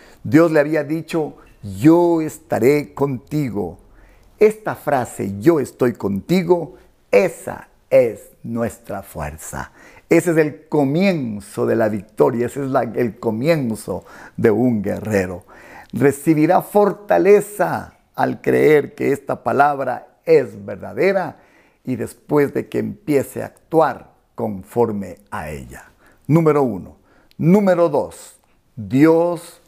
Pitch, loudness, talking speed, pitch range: 145 Hz, -18 LUFS, 110 wpm, 110-170 Hz